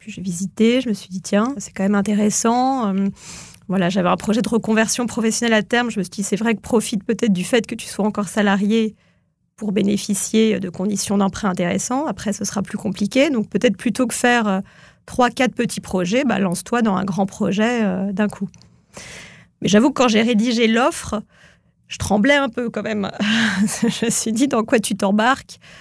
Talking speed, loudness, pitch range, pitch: 205 wpm, -19 LUFS, 195-235 Hz, 215 Hz